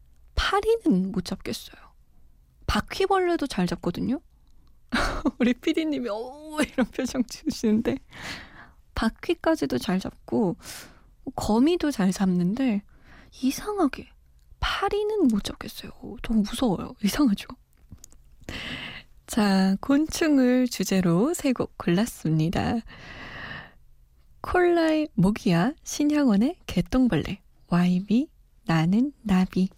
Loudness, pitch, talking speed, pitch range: -25 LUFS, 240 Hz, 210 characters per minute, 185-290 Hz